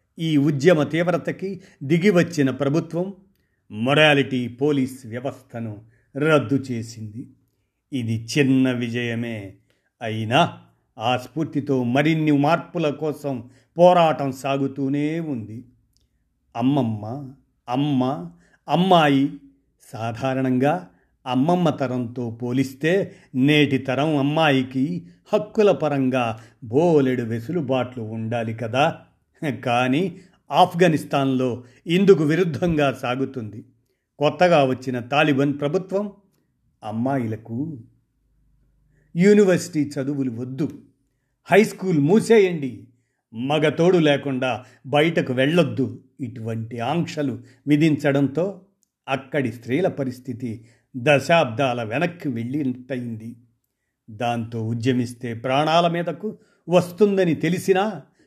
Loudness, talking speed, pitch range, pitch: -21 LUFS, 75 wpm, 125-160 Hz, 135 Hz